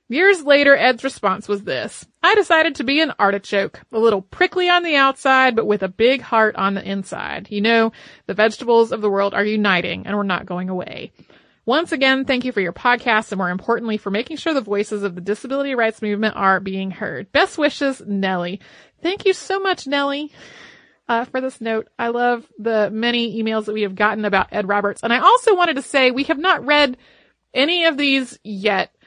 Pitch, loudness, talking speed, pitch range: 230 Hz, -18 LUFS, 210 wpm, 205-275 Hz